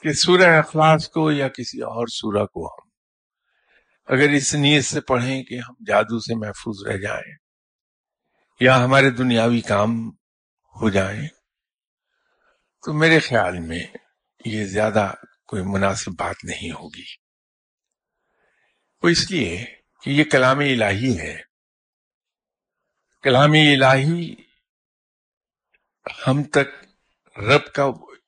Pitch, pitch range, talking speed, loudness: 130 Hz, 110-150 Hz, 110 wpm, -19 LUFS